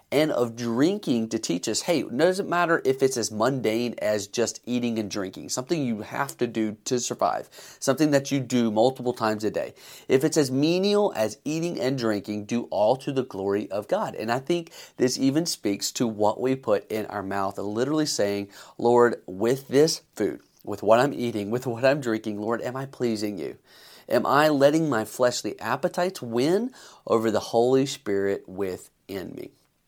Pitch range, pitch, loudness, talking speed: 110-135 Hz, 120 Hz, -25 LUFS, 190 wpm